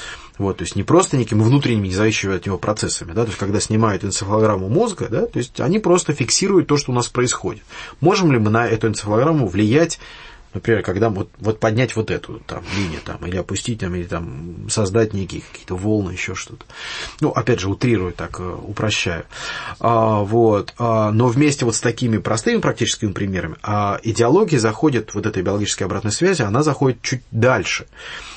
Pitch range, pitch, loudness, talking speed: 100-120 Hz, 110 Hz, -19 LUFS, 185 wpm